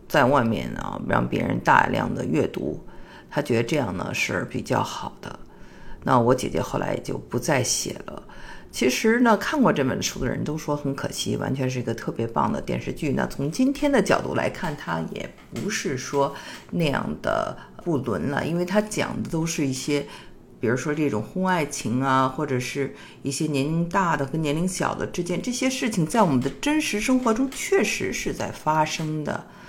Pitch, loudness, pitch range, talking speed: 155 Hz, -24 LUFS, 140-200 Hz, 275 characters per minute